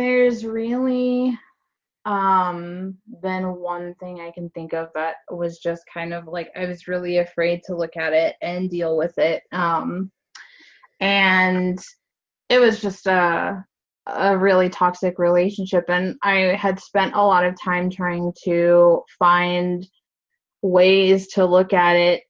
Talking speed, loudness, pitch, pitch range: 145 wpm, -20 LUFS, 180 Hz, 175-195 Hz